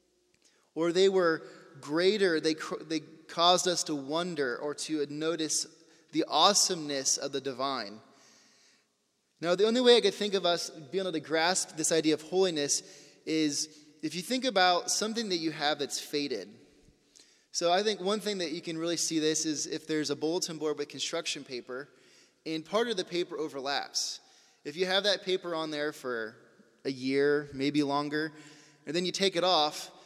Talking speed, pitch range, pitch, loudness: 180 wpm, 150-180 Hz, 160 Hz, -29 LUFS